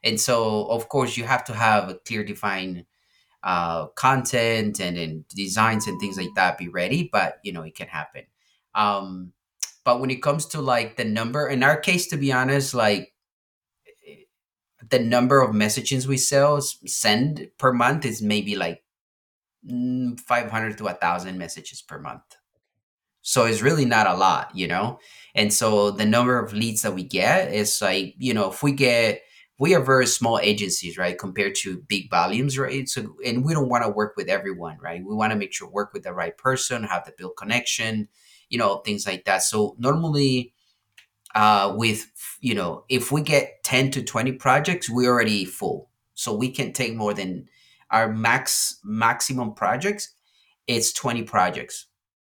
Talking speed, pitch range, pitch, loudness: 180 wpm, 105-130 Hz, 115 Hz, -22 LUFS